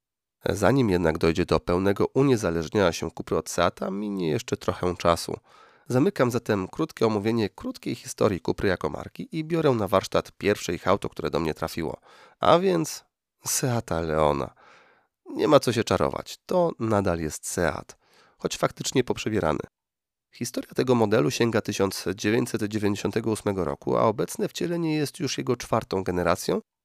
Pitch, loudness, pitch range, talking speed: 105 Hz, -25 LUFS, 90-130 Hz, 145 wpm